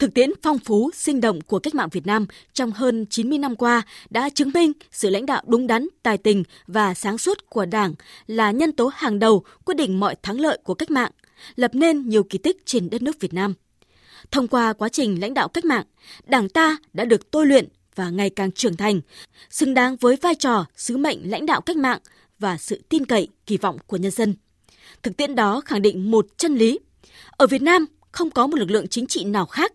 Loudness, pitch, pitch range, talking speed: -21 LUFS, 235 Hz, 205-290 Hz, 230 wpm